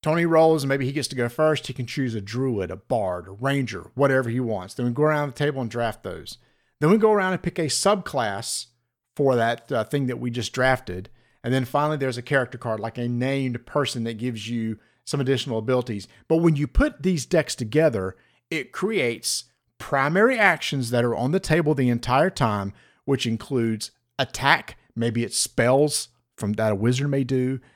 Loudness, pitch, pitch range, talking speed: -23 LUFS, 130 Hz, 115-145 Hz, 205 wpm